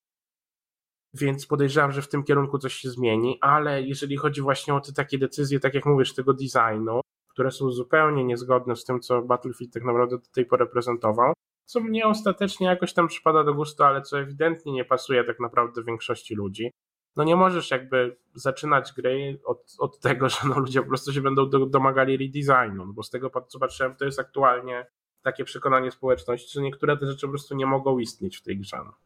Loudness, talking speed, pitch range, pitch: -24 LUFS, 200 wpm, 125-140 Hz, 135 Hz